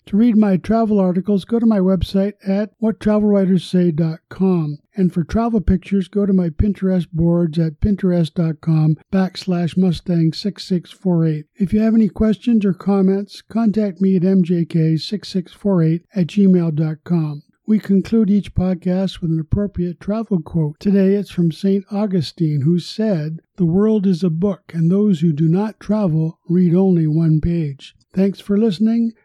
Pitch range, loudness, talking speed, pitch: 170-205 Hz, -18 LUFS, 150 wpm, 185 Hz